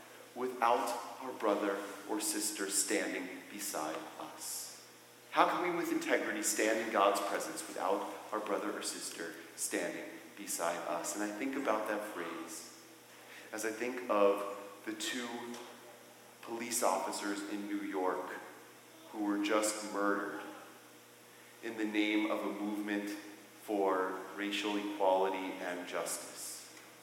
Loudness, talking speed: -36 LUFS, 125 wpm